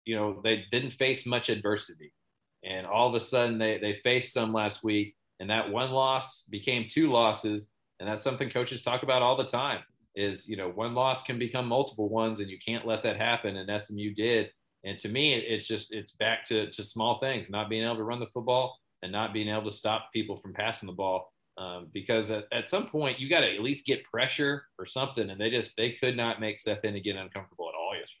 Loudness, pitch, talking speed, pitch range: -30 LUFS, 110 Hz, 235 wpm, 105-125 Hz